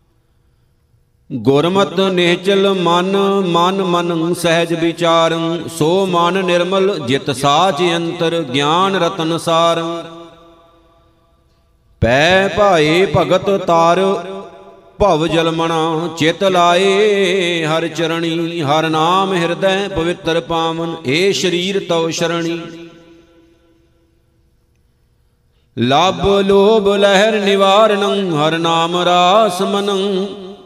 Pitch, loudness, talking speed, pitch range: 170 Hz, -14 LUFS, 85 wpm, 165-195 Hz